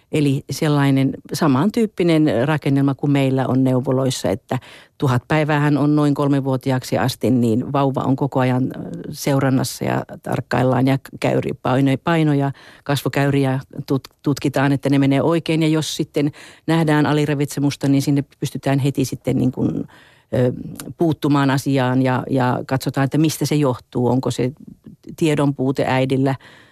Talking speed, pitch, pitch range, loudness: 130 wpm, 140 Hz, 130-145 Hz, -19 LUFS